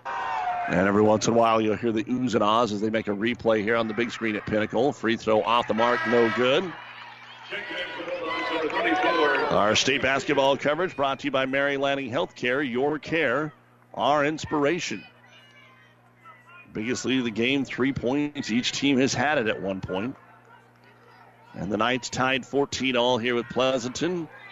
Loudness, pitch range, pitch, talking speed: -24 LUFS, 110-135 Hz, 125 Hz, 170 wpm